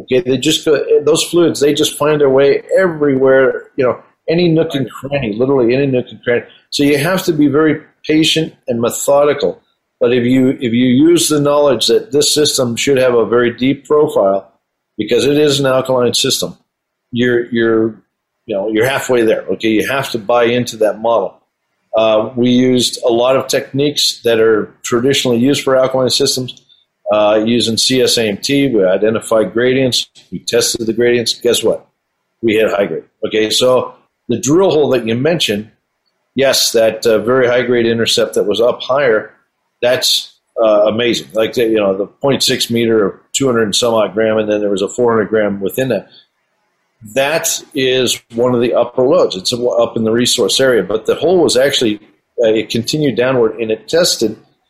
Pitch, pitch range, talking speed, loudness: 125 Hz, 115-145 Hz, 185 wpm, -13 LUFS